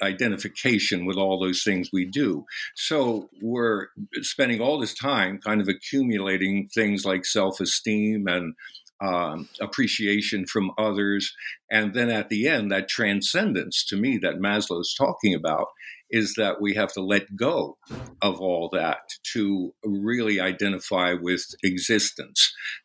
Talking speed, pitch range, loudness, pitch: 140 wpm, 95-105 Hz, -24 LUFS, 100 Hz